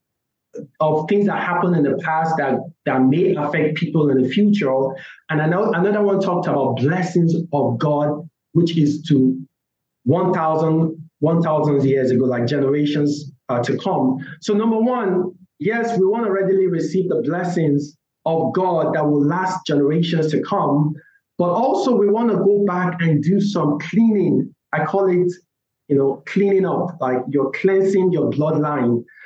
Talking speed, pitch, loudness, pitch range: 160 wpm, 160 Hz, -19 LUFS, 145-185 Hz